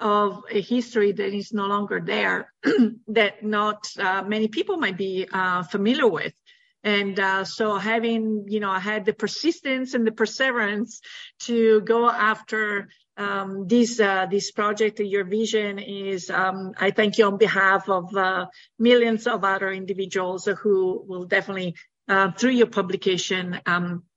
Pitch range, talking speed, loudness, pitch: 195-225 Hz, 150 wpm, -23 LUFS, 205 Hz